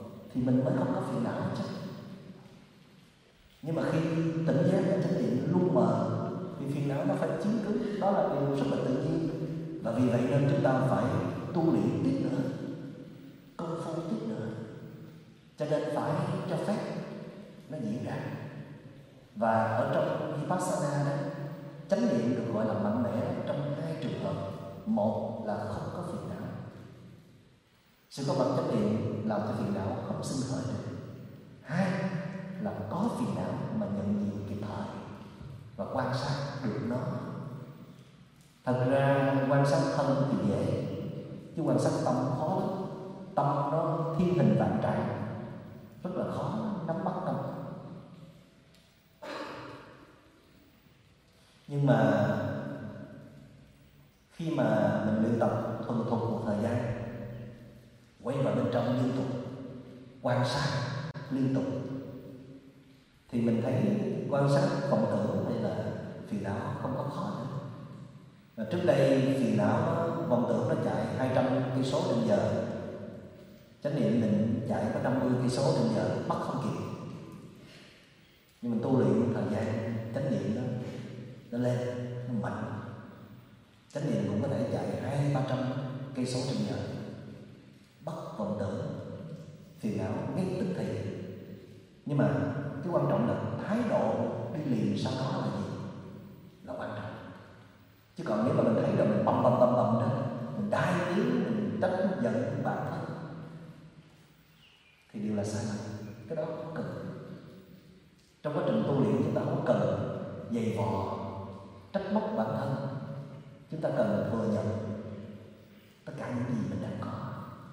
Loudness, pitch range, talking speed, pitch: -31 LUFS, 120-160 Hz, 150 wpm, 135 Hz